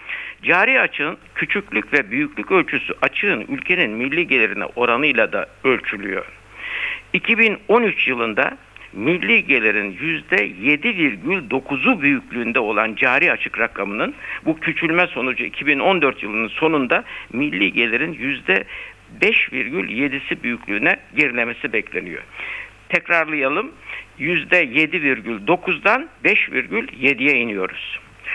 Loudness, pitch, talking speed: -18 LUFS, 170 Hz, 85 wpm